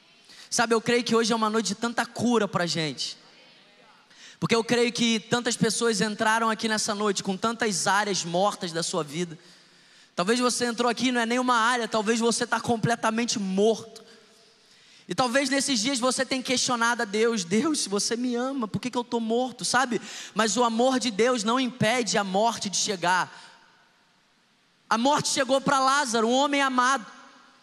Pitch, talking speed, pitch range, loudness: 230 Hz, 180 wpm, 215-245 Hz, -25 LUFS